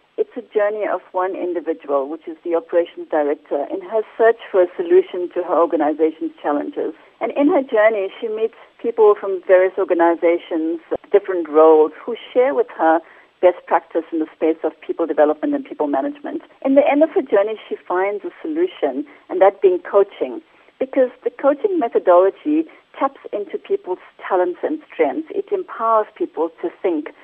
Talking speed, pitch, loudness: 170 wpm, 215 Hz, -19 LUFS